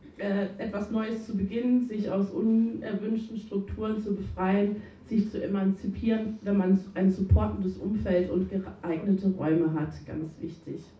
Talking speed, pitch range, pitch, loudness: 130 wpm, 190-215 Hz, 200 Hz, -29 LUFS